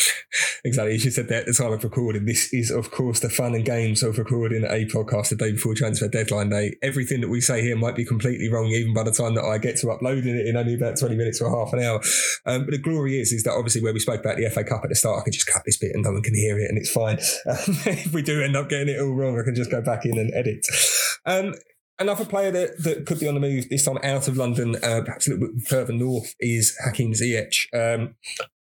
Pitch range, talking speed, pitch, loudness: 115-135 Hz, 275 wpm, 120 Hz, -23 LUFS